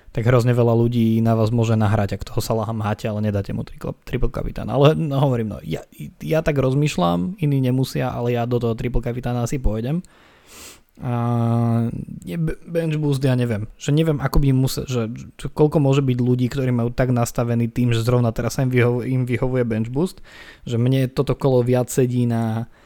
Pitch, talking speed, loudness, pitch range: 125 Hz, 190 wpm, -21 LUFS, 115-135 Hz